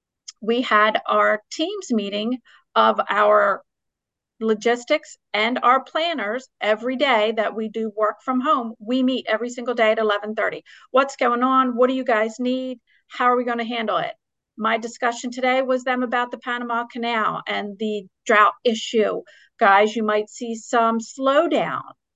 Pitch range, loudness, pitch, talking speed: 215-255 Hz, -21 LUFS, 235 Hz, 165 wpm